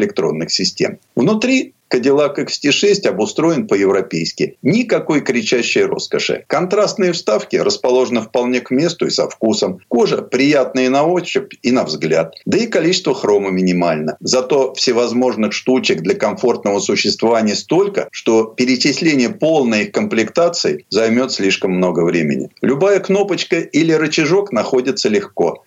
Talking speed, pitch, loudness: 125 wpm, 130 Hz, -15 LUFS